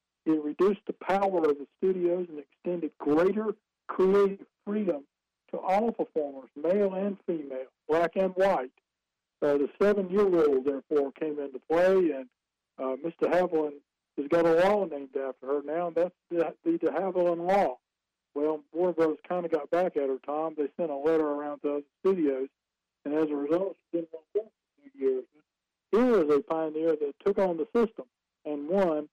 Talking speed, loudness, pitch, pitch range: 175 wpm, -28 LUFS, 160 Hz, 145-190 Hz